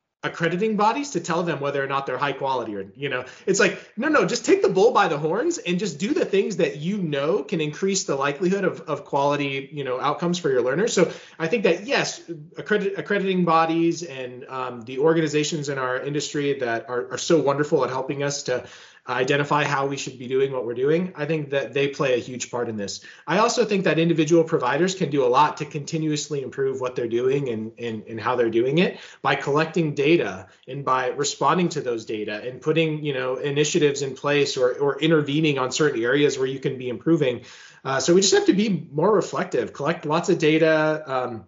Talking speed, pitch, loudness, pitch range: 220 wpm, 150 Hz, -23 LUFS, 135-170 Hz